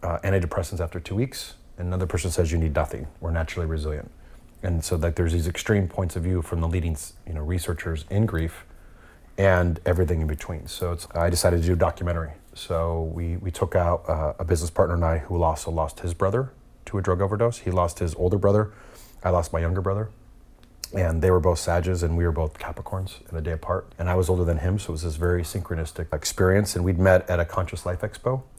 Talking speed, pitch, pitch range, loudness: 230 wpm, 90 Hz, 85-95 Hz, -25 LUFS